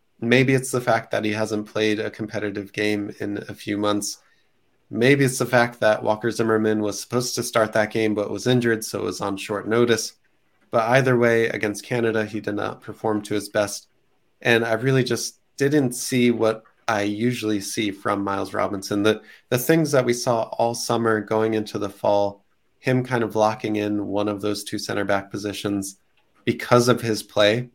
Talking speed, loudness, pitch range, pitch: 195 wpm, -22 LUFS, 105-120 Hz, 110 Hz